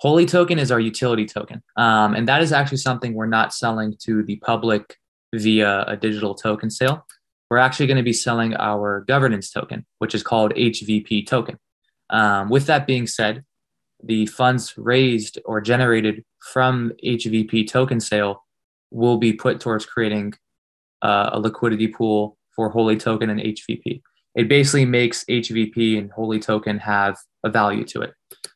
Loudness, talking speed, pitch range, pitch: -20 LUFS, 160 wpm, 105-120 Hz, 110 Hz